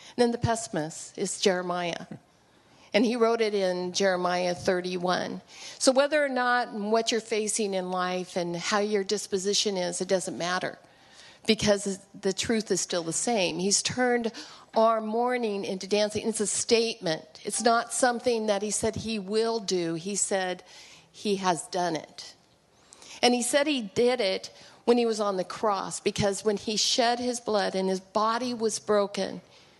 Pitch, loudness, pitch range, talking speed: 205 Hz, -27 LUFS, 185-230 Hz, 165 wpm